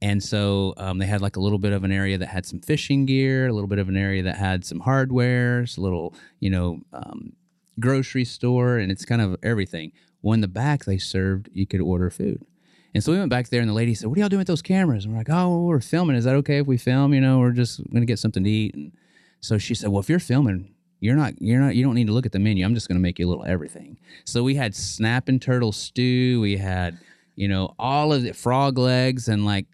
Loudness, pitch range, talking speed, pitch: -22 LUFS, 95-130 Hz, 270 wpm, 115 Hz